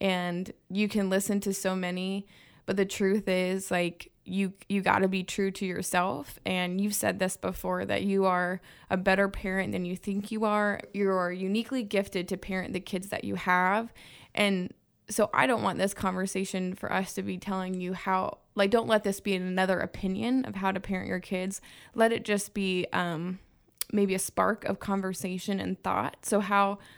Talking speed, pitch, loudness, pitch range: 190 wpm, 190 Hz, -29 LUFS, 185-200 Hz